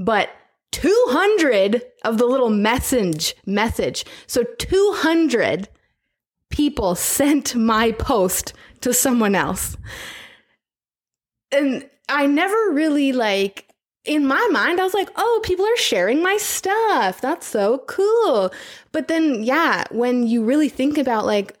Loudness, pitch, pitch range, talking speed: -19 LUFS, 280 Hz, 235-370 Hz, 125 wpm